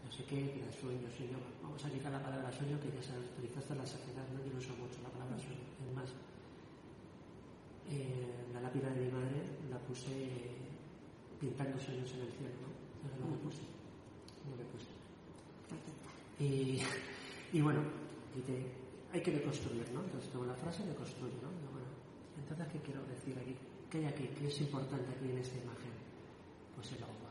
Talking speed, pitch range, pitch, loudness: 190 wpm, 125-140 Hz, 130 Hz, -44 LUFS